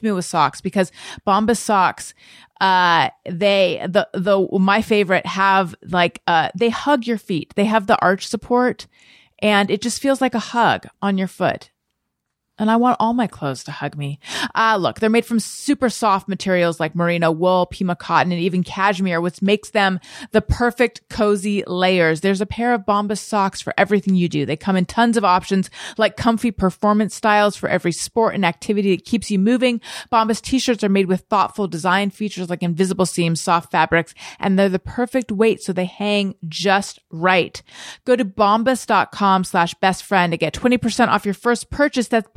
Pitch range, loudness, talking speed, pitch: 180-225 Hz, -18 LUFS, 190 wpm, 200 Hz